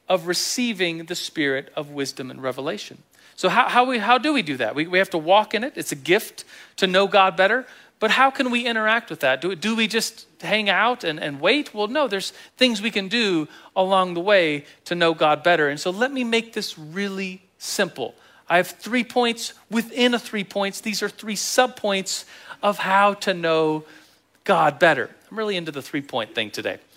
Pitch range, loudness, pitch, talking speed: 175-230 Hz, -21 LUFS, 200 Hz, 215 wpm